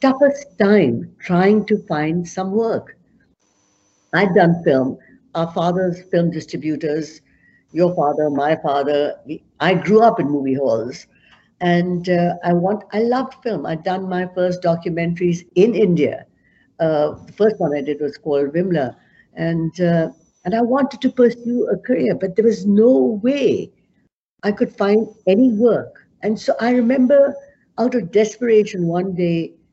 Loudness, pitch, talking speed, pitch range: -18 LUFS, 180 Hz, 150 wpm, 165-220 Hz